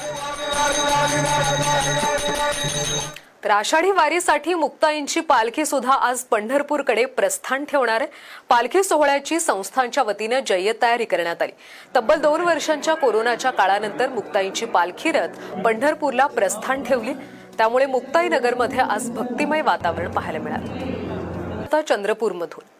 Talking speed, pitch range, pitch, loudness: 90 wpm, 215-295 Hz, 260 Hz, -20 LUFS